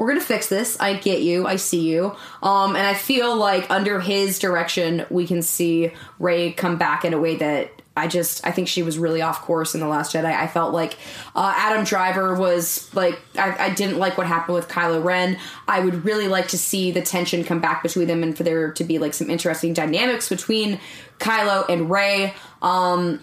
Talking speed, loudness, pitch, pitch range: 215 wpm, -21 LUFS, 175 Hz, 165-195 Hz